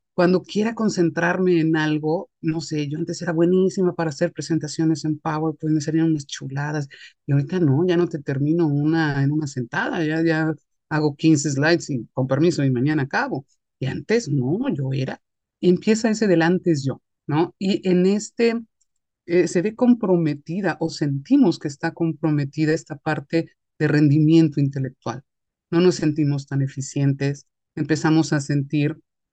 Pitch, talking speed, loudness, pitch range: 160 Hz, 165 wpm, -21 LUFS, 145-170 Hz